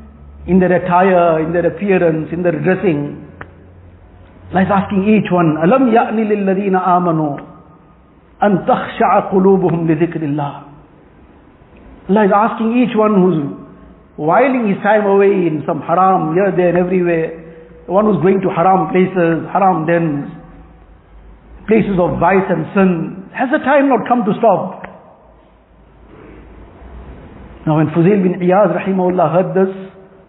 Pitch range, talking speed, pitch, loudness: 160-195 Hz, 125 wpm, 180 Hz, -14 LUFS